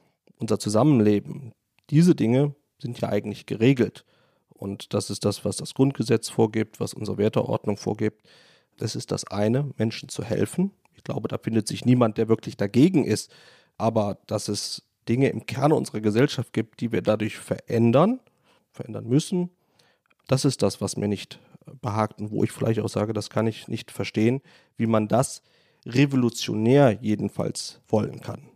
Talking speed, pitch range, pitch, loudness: 160 wpm, 105-135 Hz, 115 Hz, -24 LUFS